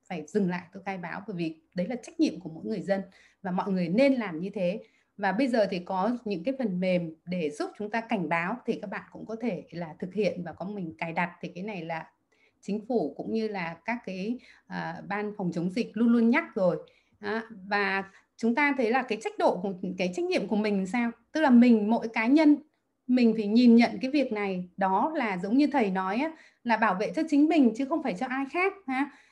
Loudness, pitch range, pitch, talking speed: -28 LUFS, 190-250 Hz, 215 Hz, 245 wpm